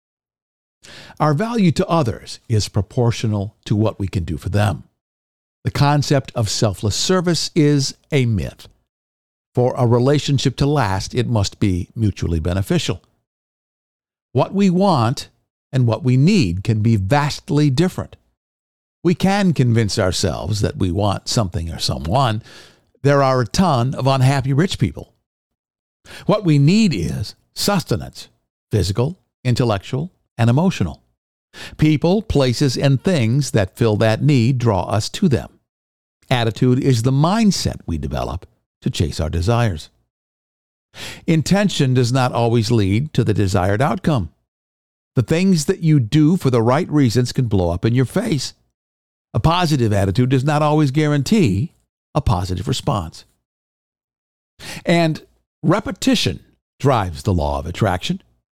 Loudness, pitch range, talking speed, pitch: -18 LUFS, 100-150 Hz, 135 wpm, 125 Hz